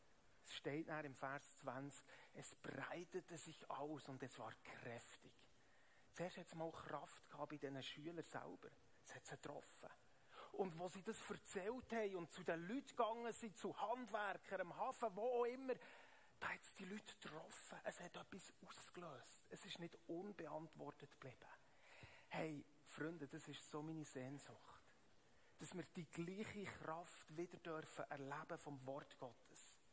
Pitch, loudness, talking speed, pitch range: 165 Hz, -52 LUFS, 160 wpm, 145-190 Hz